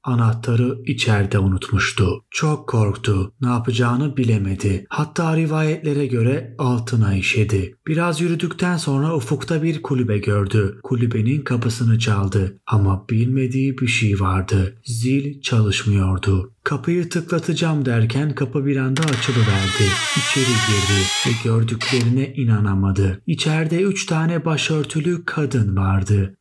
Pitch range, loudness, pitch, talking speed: 105-145 Hz, -19 LUFS, 125 Hz, 110 wpm